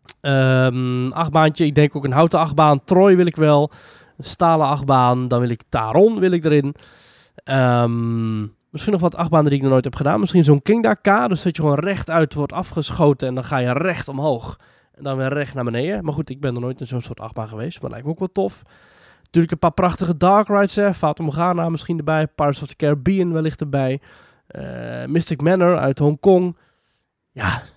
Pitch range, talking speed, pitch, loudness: 130-170 Hz, 200 wpm, 150 Hz, -18 LUFS